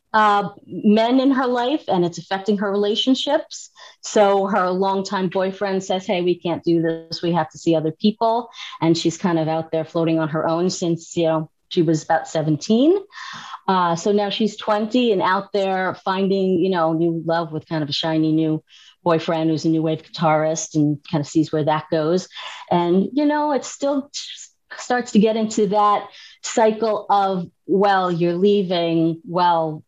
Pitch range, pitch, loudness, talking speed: 165-215 Hz, 185 Hz, -20 LUFS, 185 wpm